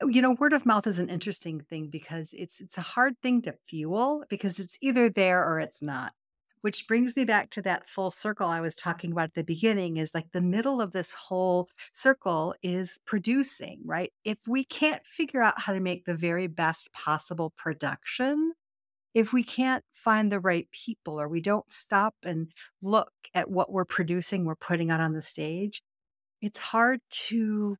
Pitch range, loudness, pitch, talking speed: 170-230 Hz, -28 LUFS, 190 Hz, 190 wpm